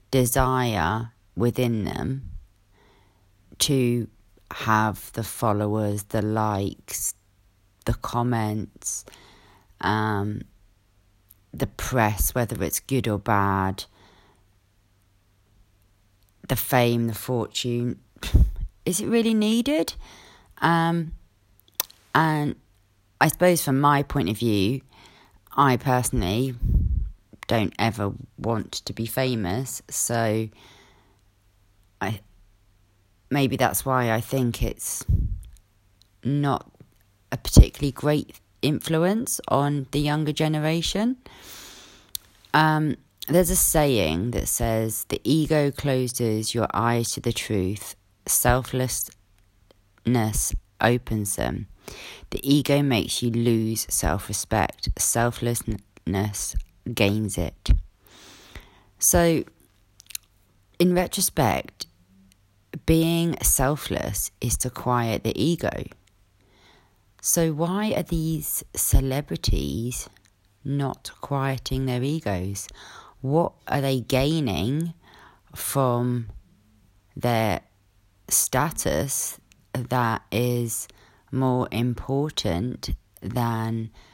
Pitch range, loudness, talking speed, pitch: 100-130 Hz, -24 LUFS, 85 wpm, 110 Hz